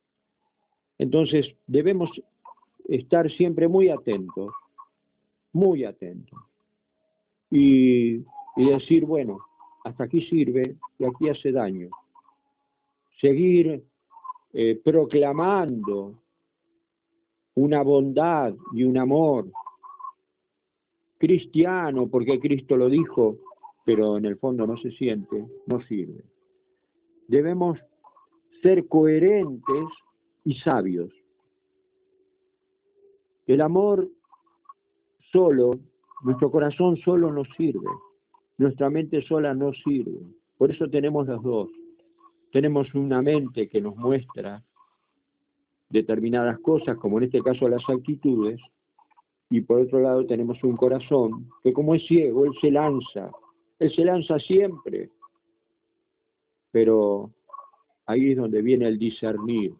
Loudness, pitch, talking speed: -23 LUFS, 160 Hz, 105 wpm